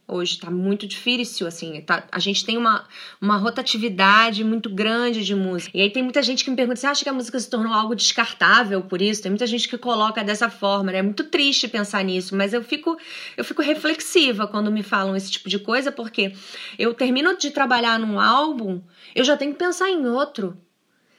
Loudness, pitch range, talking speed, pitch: -21 LUFS, 200-255 Hz, 210 wpm, 225 Hz